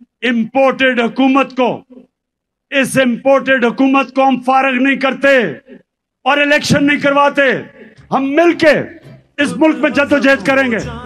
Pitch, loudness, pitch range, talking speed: 270 Hz, -12 LUFS, 255-280 Hz, 120 wpm